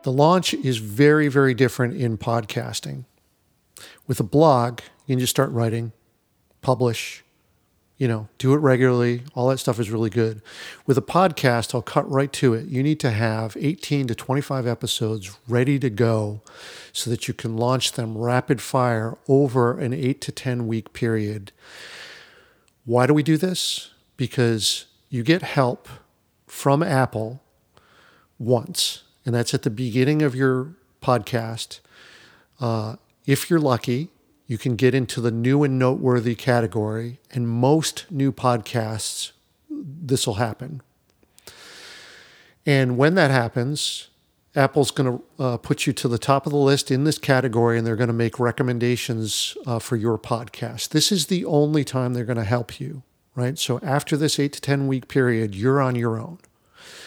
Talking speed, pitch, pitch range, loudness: 160 wpm, 125 Hz, 115-140 Hz, -22 LUFS